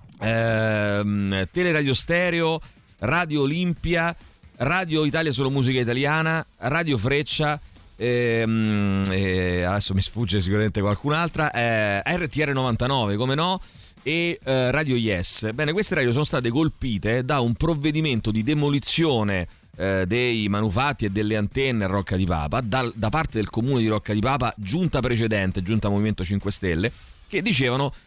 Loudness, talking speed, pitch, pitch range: -23 LUFS, 140 wpm, 120 Hz, 105-150 Hz